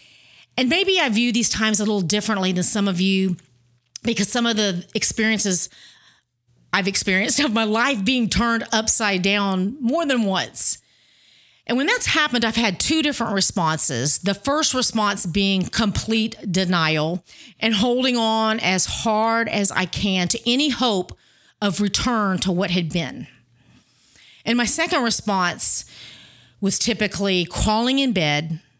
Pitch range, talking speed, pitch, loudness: 185-235 Hz, 150 wpm, 210 Hz, -19 LUFS